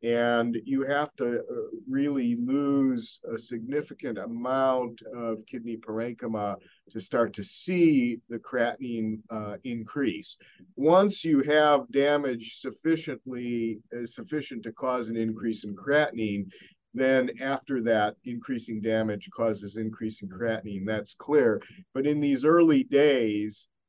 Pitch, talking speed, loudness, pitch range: 120 Hz, 125 wpm, -28 LUFS, 110-140 Hz